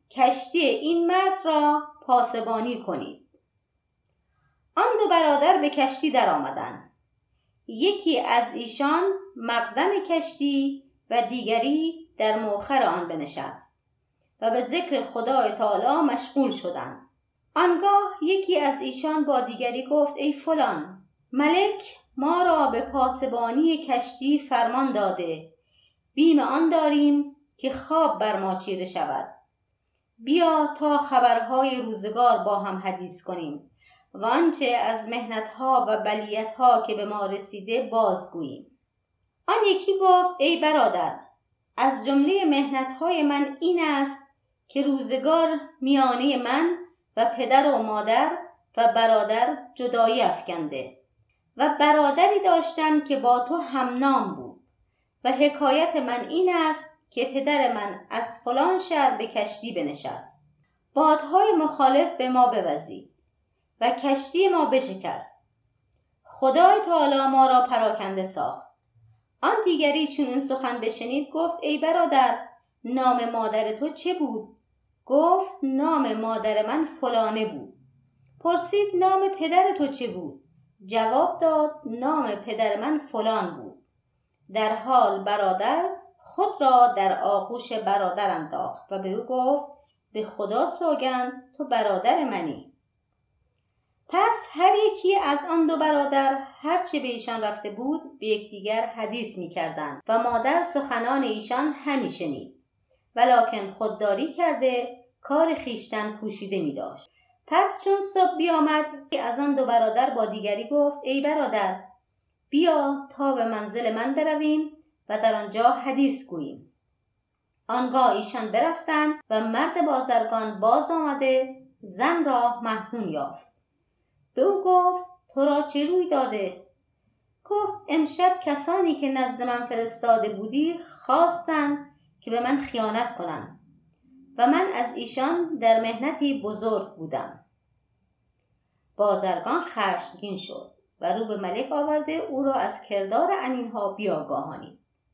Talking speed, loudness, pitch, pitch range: 125 wpm, -24 LUFS, 265 Hz, 225-310 Hz